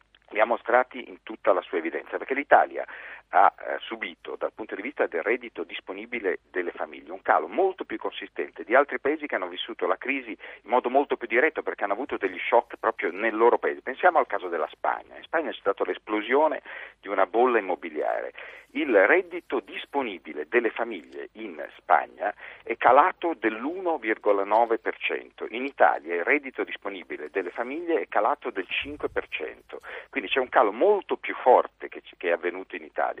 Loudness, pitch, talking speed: -26 LUFS, 375 Hz, 170 wpm